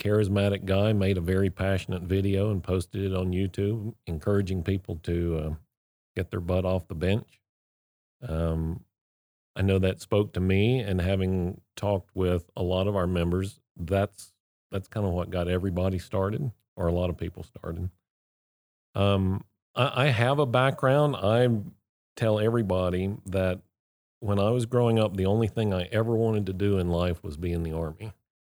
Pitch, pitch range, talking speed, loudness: 95 Hz, 90-105 Hz, 175 wpm, -27 LUFS